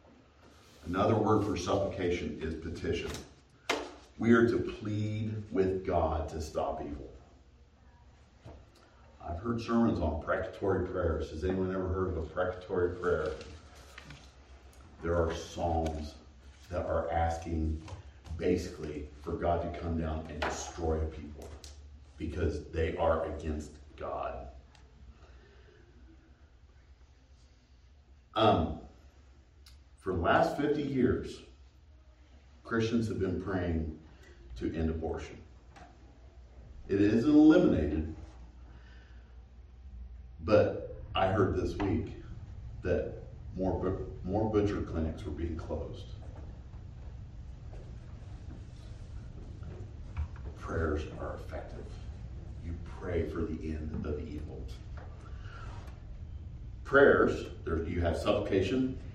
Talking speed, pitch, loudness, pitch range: 95 wpm, 80 Hz, -32 LUFS, 75-90 Hz